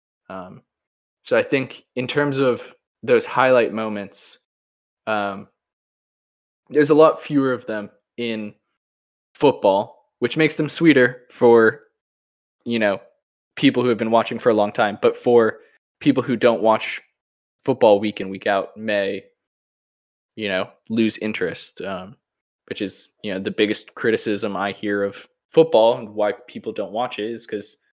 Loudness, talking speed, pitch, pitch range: -20 LUFS, 150 wpm, 115 Hz, 100-130 Hz